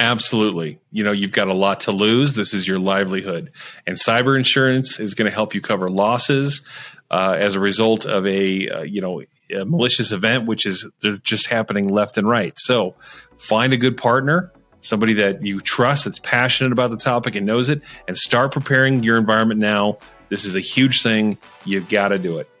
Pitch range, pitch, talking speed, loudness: 100-125 Hz, 110 Hz, 200 wpm, -18 LUFS